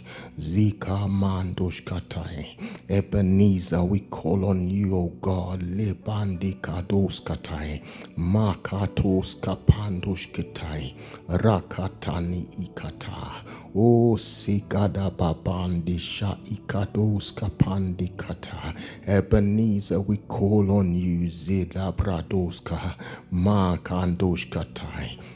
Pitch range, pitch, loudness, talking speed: 90-100 Hz, 95 Hz, -26 LUFS, 65 wpm